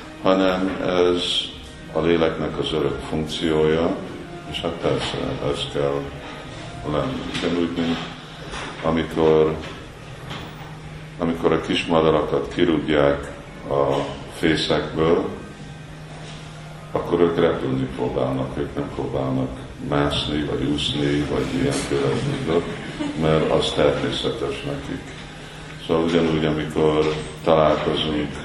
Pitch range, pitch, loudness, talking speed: 70-80 Hz, 75 Hz, -22 LUFS, 90 wpm